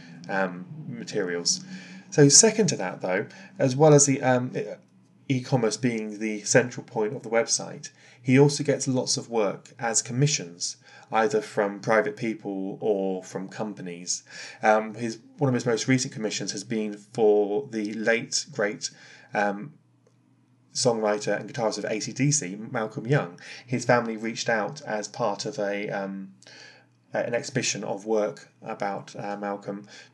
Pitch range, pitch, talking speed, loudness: 105-135 Hz, 110 Hz, 145 wpm, -25 LUFS